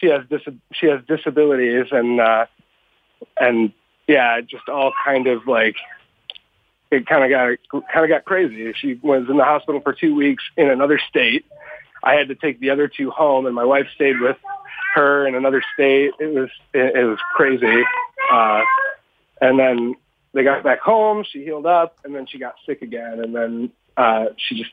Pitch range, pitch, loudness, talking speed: 130-160 Hz, 140 Hz, -18 LUFS, 190 wpm